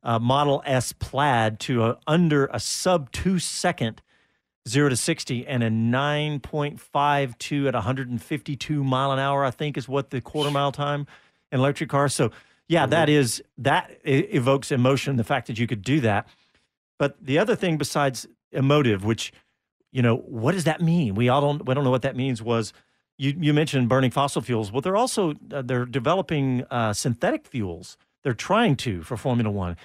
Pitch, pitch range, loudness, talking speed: 135 Hz, 120-145 Hz, -24 LUFS, 195 wpm